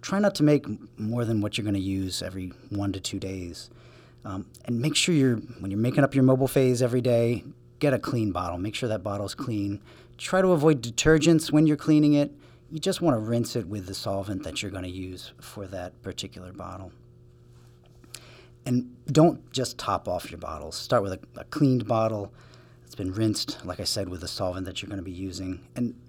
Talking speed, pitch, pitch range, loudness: 215 wpm, 120 Hz, 100-125 Hz, -26 LUFS